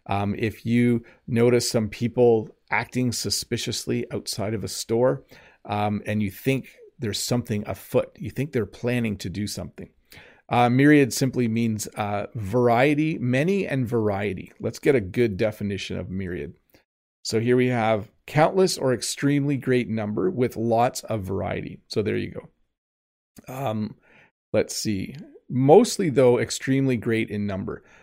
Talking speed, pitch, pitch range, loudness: 145 wpm, 115 Hz, 105-125 Hz, -24 LUFS